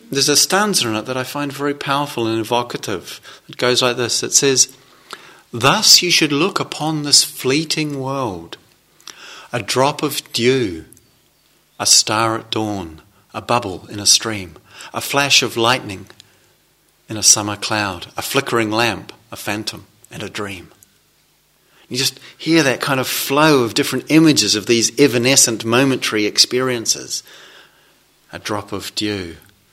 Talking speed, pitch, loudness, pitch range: 150 wpm, 120 Hz, -15 LUFS, 105-140 Hz